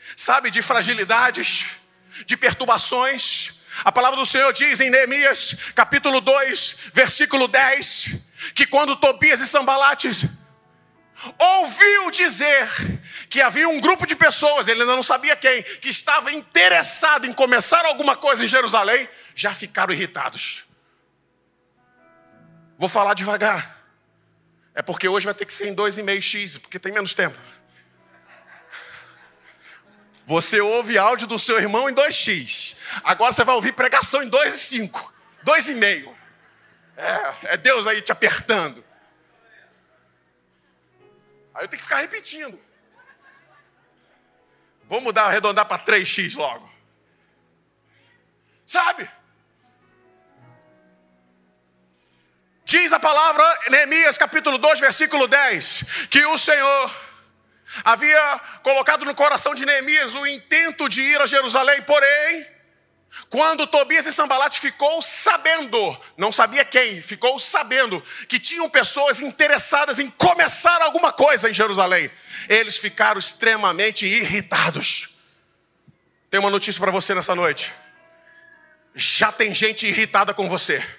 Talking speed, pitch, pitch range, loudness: 120 wpm, 265 Hz, 205-295 Hz, -16 LUFS